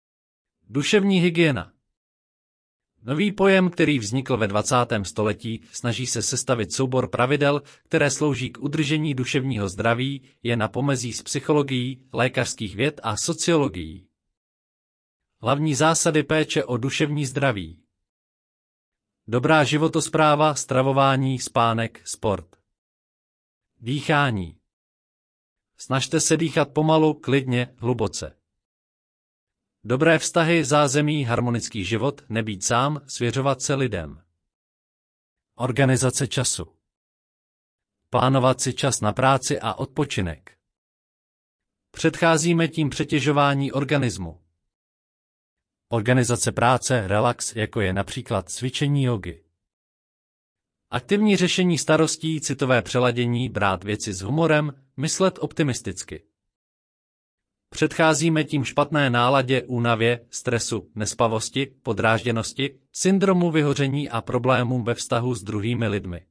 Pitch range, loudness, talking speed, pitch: 110-145 Hz, -22 LUFS, 95 wpm, 125 Hz